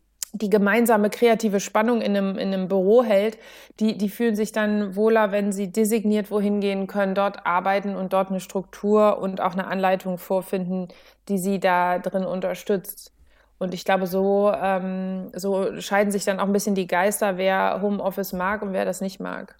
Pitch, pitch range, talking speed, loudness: 200 Hz, 190-210 Hz, 185 wpm, -23 LUFS